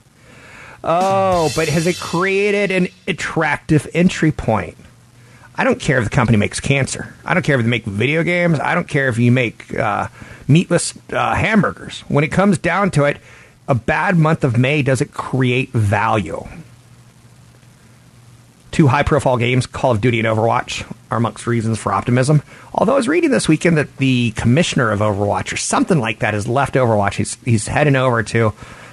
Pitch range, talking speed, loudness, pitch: 115-160 Hz, 180 wpm, -17 LUFS, 130 Hz